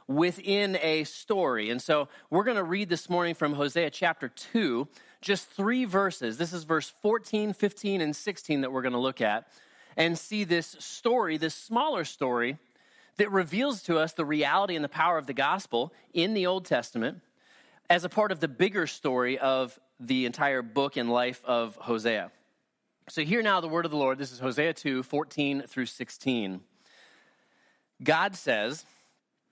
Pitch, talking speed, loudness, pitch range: 160 Hz, 175 wpm, -29 LUFS, 130-190 Hz